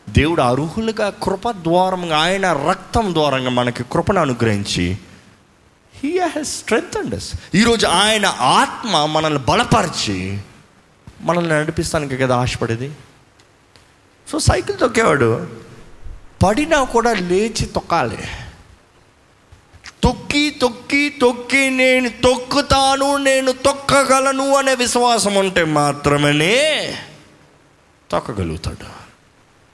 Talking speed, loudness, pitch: 85 wpm, -17 LUFS, 190 Hz